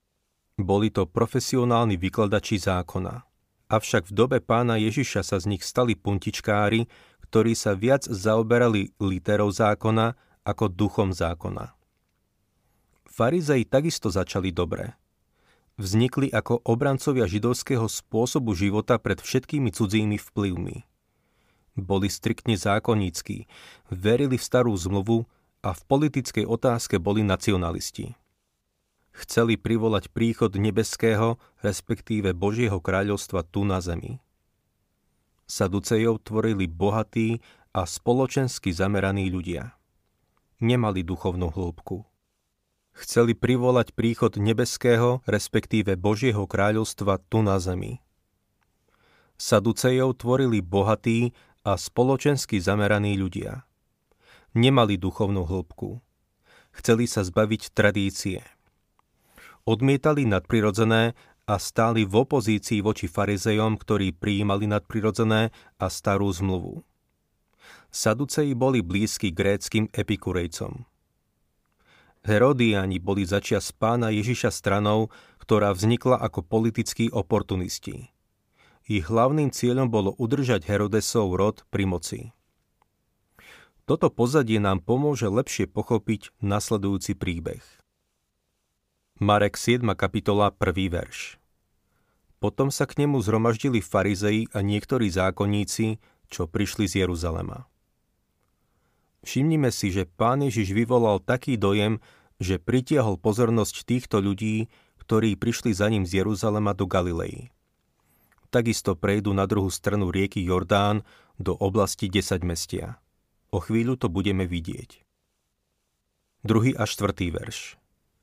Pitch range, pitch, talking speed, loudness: 100-115 Hz, 105 Hz, 105 wpm, -25 LUFS